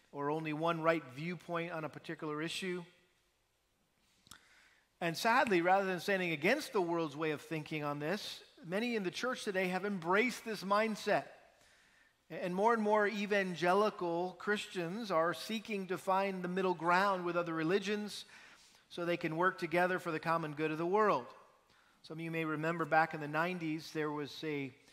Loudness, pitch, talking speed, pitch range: -35 LUFS, 175 Hz, 170 wpm, 160-200 Hz